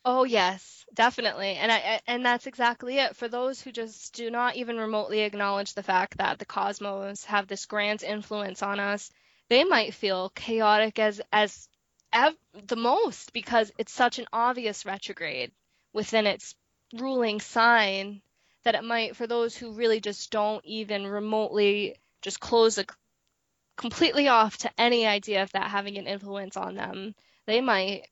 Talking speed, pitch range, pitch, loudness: 160 wpm, 200-235 Hz, 215 Hz, -27 LUFS